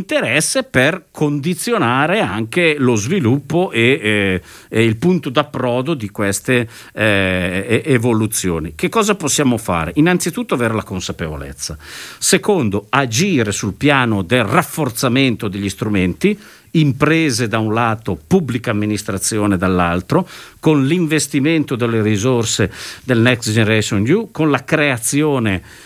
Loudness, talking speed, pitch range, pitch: -16 LUFS, 115 wpm, 105-150 Hz, 120 Hz